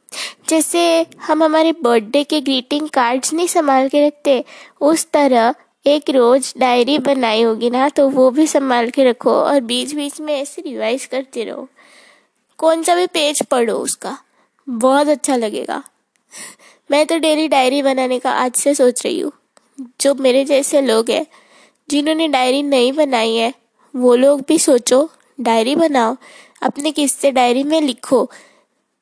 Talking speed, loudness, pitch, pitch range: 155 wpm, -15 LUFS, 275 Hz, 255-300 Hz